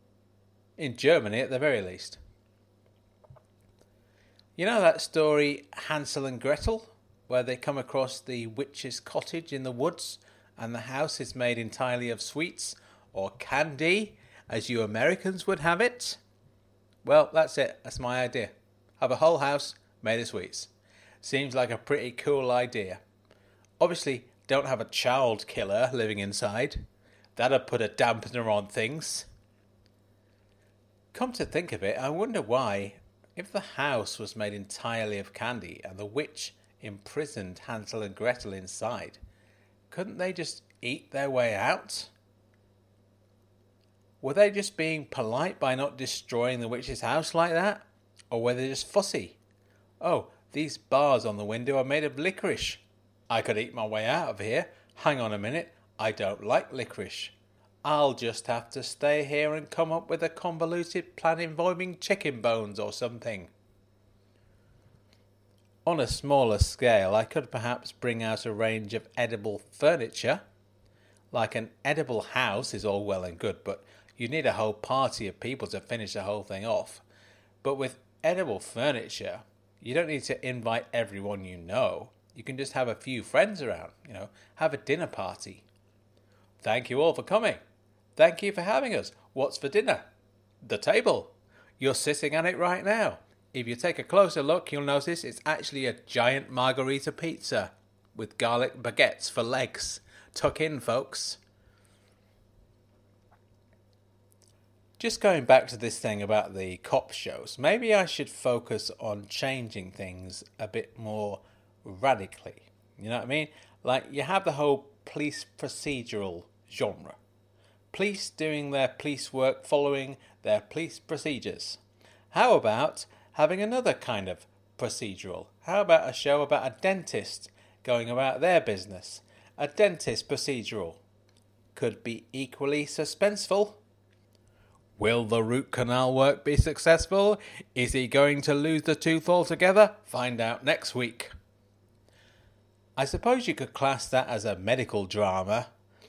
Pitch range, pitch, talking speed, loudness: 105-145 Hz, 115 Hz, 150 wpm, -29 LUFS